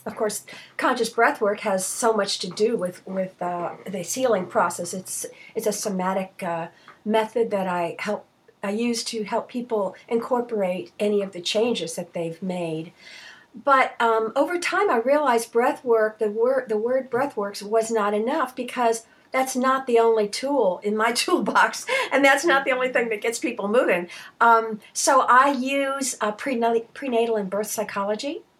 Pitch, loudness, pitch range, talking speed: 225 Hz, -23 LUFS, 200-255 Hz, 175 wpm